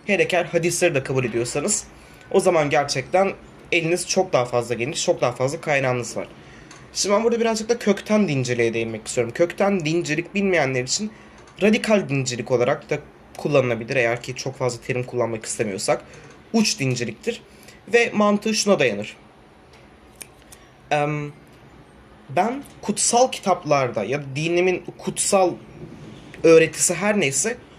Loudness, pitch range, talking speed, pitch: -21 LUFS, 130-200 Hz, 130 wpm, 170 Hz